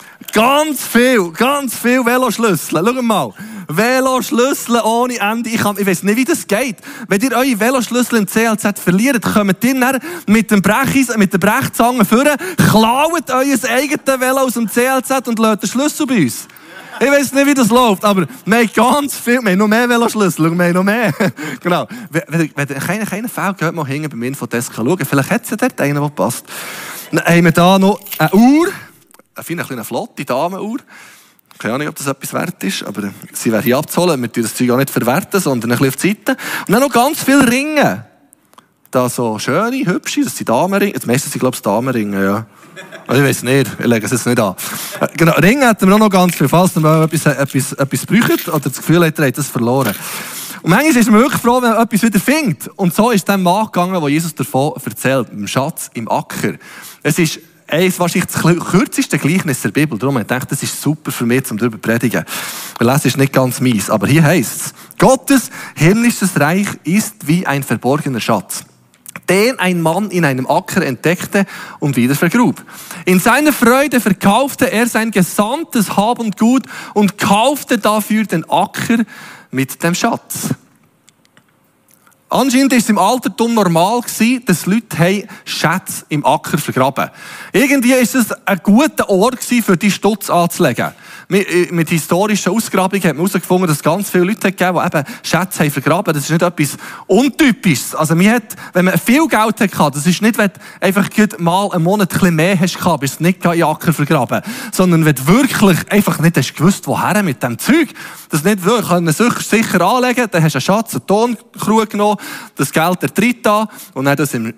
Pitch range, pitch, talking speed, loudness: 155-230 Hz, 195 Hz, 195 wpm, -14 LUFS